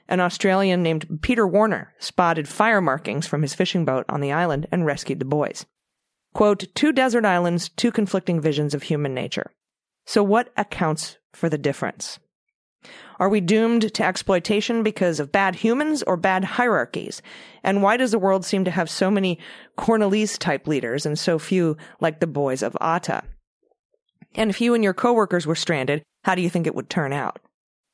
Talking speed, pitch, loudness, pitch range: 180 wpm, 185 Hz, -22 LUFS, 155-215 Hz